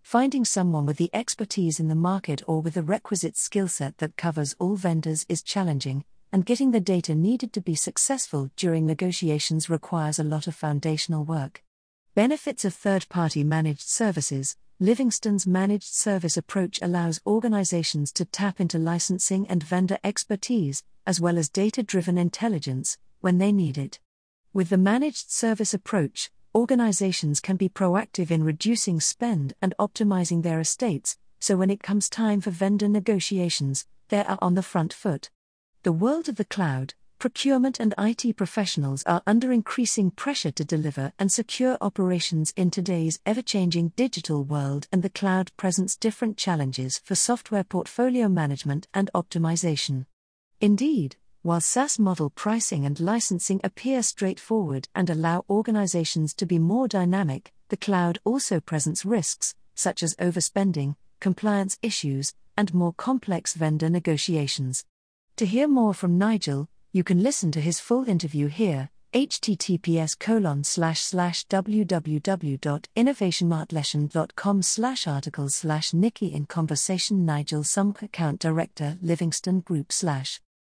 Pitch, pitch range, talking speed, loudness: 180 Hz, 160-205 Hz, 145 wpm, -25 LUFS